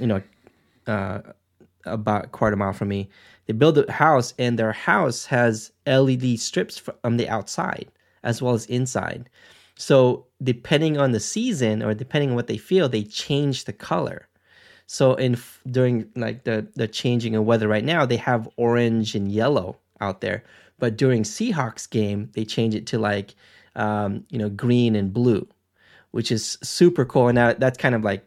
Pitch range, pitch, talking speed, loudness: 110-130 Hz, 120 Hz, 180 wpm, -22 LUFS